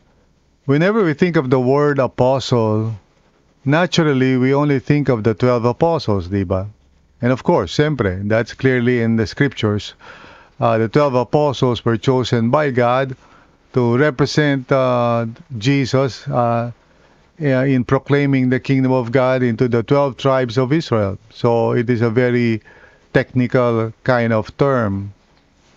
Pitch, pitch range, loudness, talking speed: 125 Hz, 115-135 Hz, -17 LUFS, 135 wpm